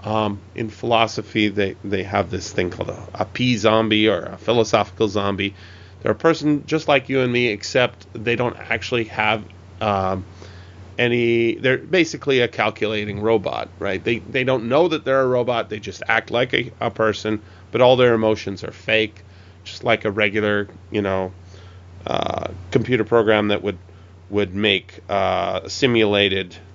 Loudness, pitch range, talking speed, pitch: -20 LUFS, 95-115 Hz, 165 wpm, 105 Hz